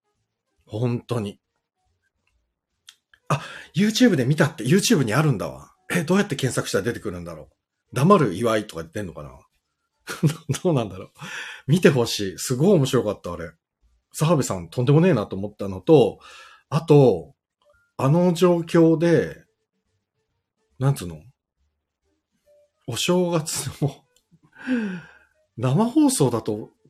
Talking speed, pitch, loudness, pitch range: 270 characters per minute, 135 Hz, -21 LUFS, 105-170 Hz